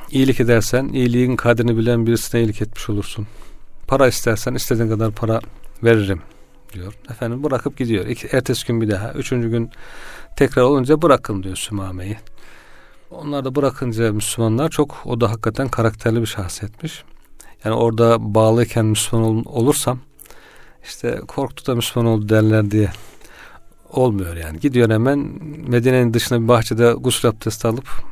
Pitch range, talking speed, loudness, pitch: 110-125 Hz, 140 wpm, -18 LUFS, 115 Hz